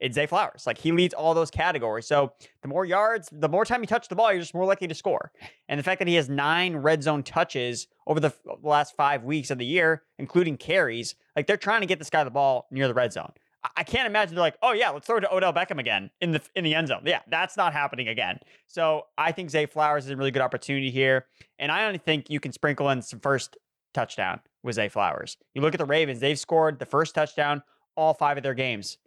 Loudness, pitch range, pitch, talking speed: -25 LUFS, 140-170 Hz, 155 Hz, 265 wpm